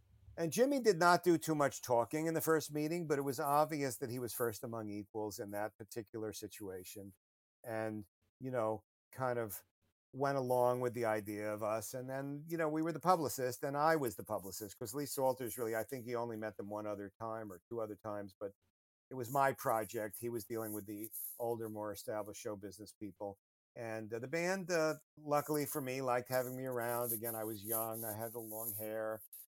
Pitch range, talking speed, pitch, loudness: 105-140 Hz, 215 wpm, 115 Hz, -38 LUFS